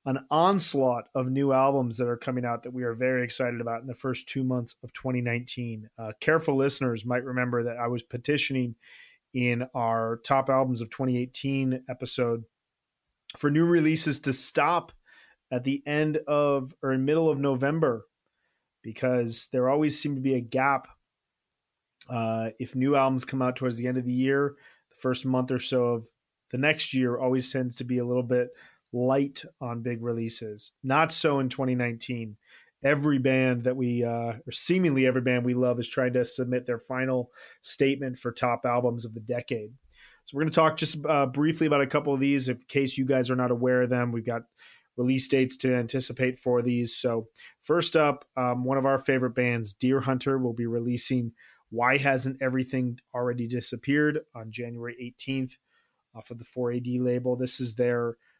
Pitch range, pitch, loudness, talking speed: 120-135 Hz, 125 Hz, -27 LUFS, 185 wpm